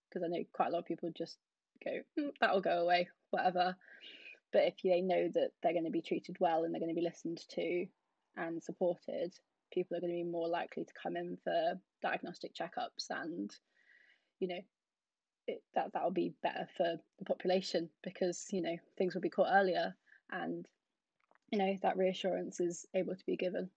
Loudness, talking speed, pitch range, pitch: -37 LUFS, 195 wpm, 170-190 Hz, 180 Hz